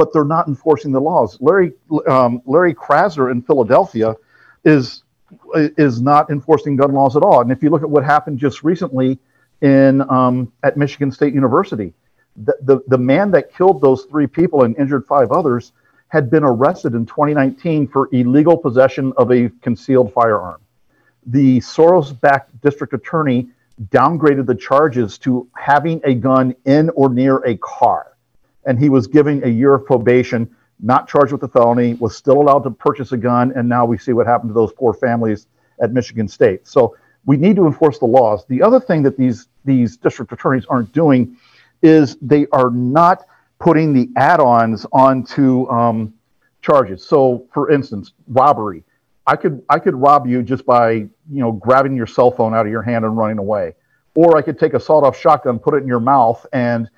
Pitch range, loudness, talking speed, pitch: 120-145 Hz, -14 LUFS, 185 wpm, 130 Hz